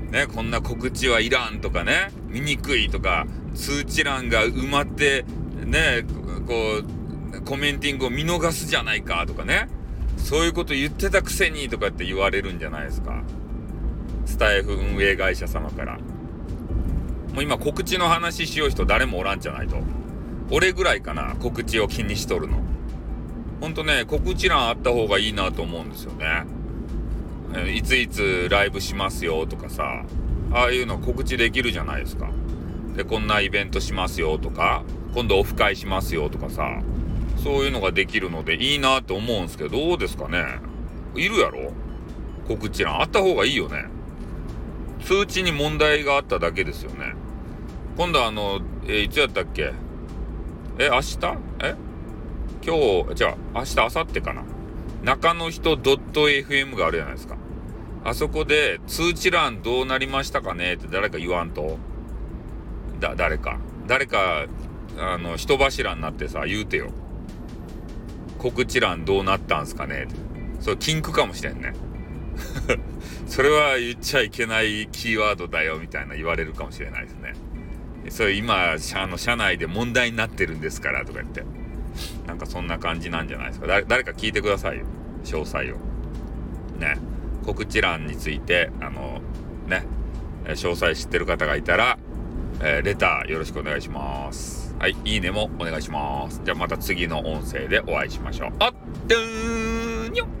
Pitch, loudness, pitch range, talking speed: 95 Hz, -23 LUFS, 80-130 Hz, 325 characters per minute